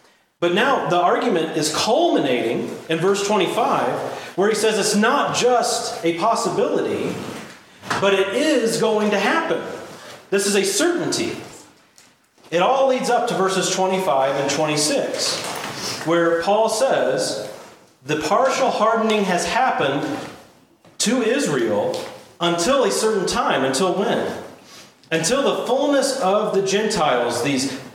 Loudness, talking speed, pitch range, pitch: -19 LUFS, 125 wpm, 175-245 Hz, 210 Hz